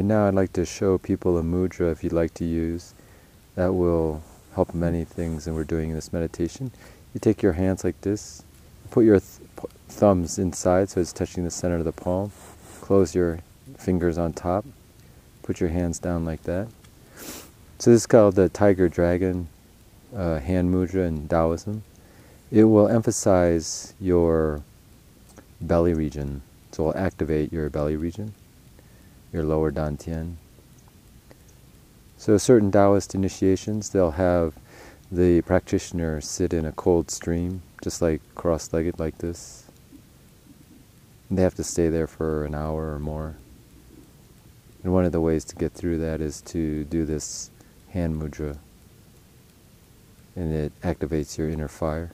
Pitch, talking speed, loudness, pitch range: 85 Hz, 155 wpm, -24 LUFS, 80-95 Hz